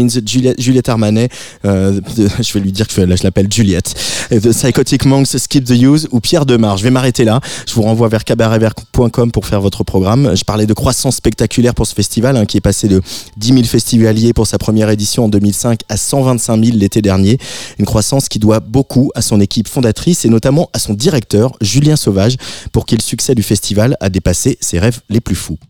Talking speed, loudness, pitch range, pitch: 210 wpm, -12 LUFS, 105-125 Hz, 115 Hz